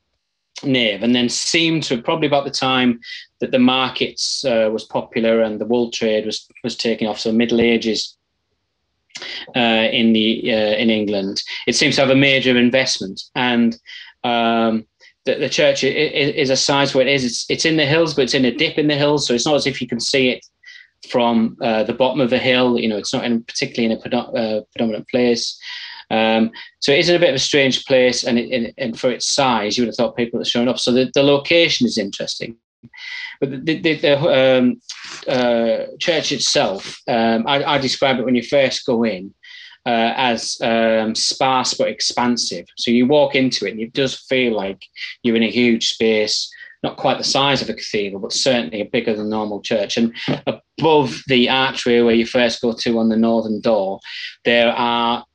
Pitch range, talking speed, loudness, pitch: 115-135 Hz, 205 wpm, -17 LUFS, 120 Hz